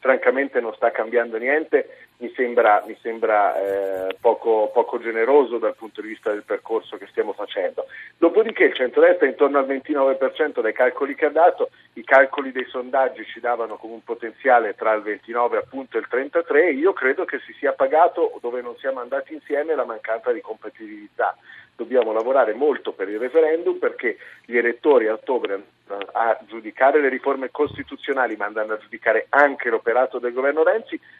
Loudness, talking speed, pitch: -21 LUFS, 175 wpm, 160 Hz